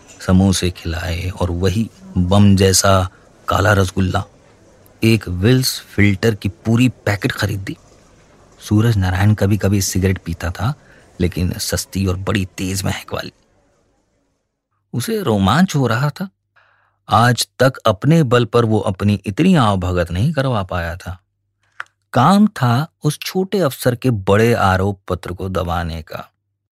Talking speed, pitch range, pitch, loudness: 135 wpm, 95-120 Hz, 100 Hz, -17 LUFS